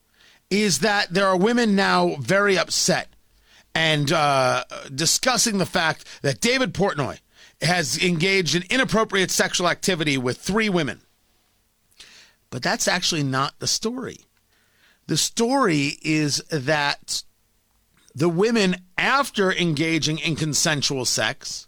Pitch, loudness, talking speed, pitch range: 175 Hz, -21 LUFS, 115 wpm, 145-200 Hz